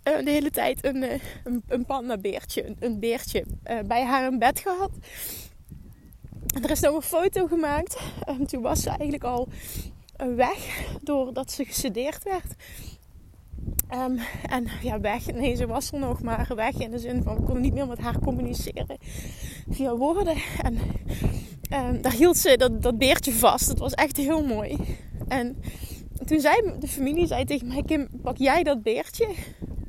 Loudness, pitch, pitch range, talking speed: -26 LUFS, 275 Hz, 250-310 Hz, 170 wpm